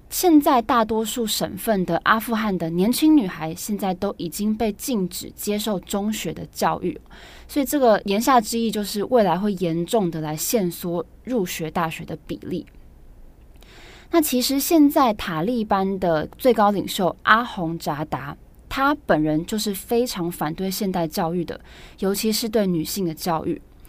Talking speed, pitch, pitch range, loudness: 245 characters per minute, 205 Hz, 170-230 Hz, -22 LUFS